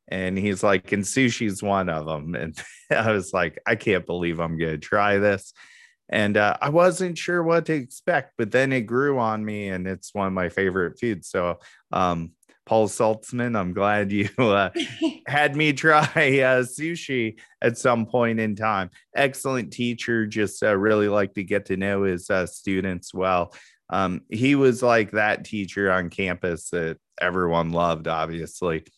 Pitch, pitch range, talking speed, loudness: 105 Hz, 95-125 Hz, 175 wpm, -23 LUFS